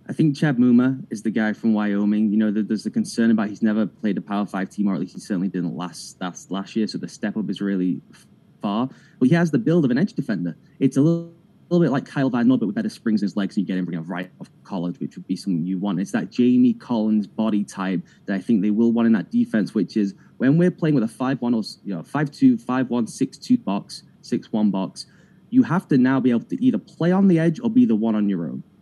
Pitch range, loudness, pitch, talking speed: 100-170 Hz, -22 LUFS, 115 Hz, 275 wpm